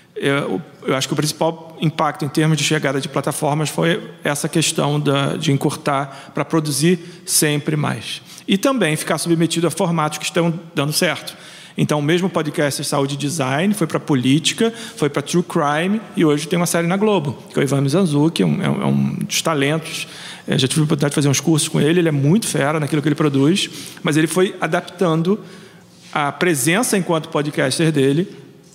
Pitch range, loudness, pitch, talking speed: 145-175 Hz, -18 LUFS, 160 Hz, 195 wpm